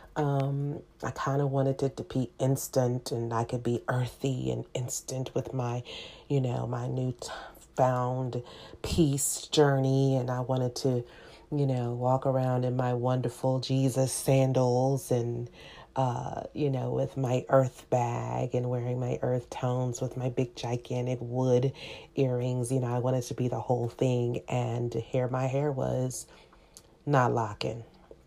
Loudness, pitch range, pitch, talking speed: -30 LUFS, 125-135 Hz, 125 Hz, 155 wpm